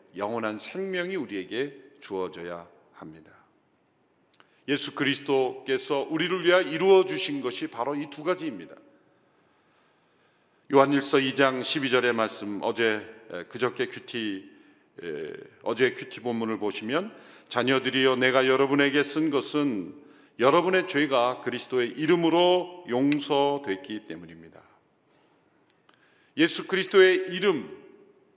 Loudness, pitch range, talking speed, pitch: -26 LUFS, 130-195 Hz, 255 characters per minute, 145 Hz